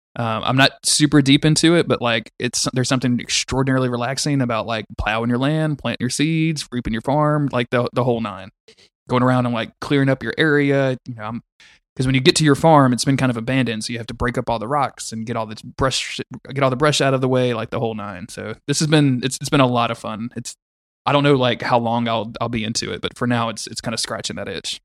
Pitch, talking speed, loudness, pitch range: 125 Hz, 270 wpm, -19 LUFS, 115-140 Hz